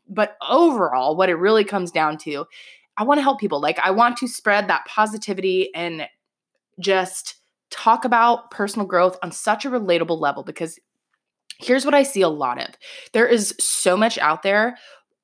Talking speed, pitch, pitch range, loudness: 175 wpm, 205 Hz, 175-235 Hz, -20 LUFS